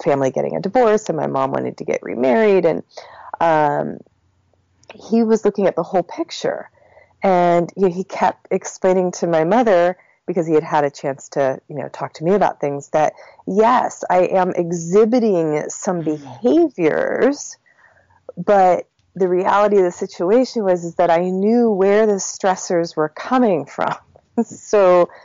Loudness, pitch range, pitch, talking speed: -18 LUFS, 160-205 Hz, 180 Hz, 160 wpm